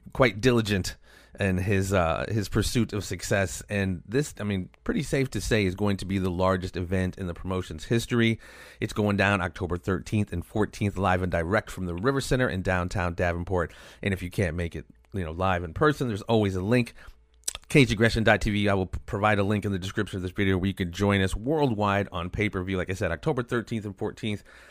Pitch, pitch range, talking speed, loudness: 100 Hz, 90-110 Hz, 210 wpm, -27 LUFS